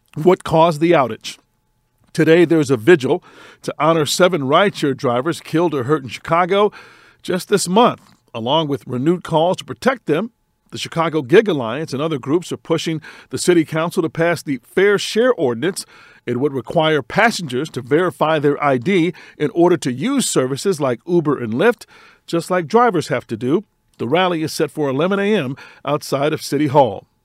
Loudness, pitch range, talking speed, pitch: -17 LUFS, 140-180 Hz, 175 wpm, 160 Hz